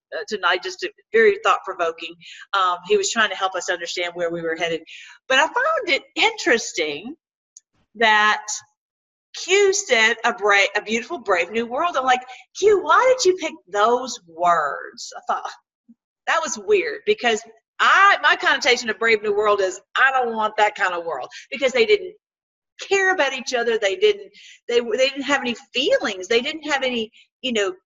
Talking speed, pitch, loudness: 180 wpm, 245 Hz, -20 LUFS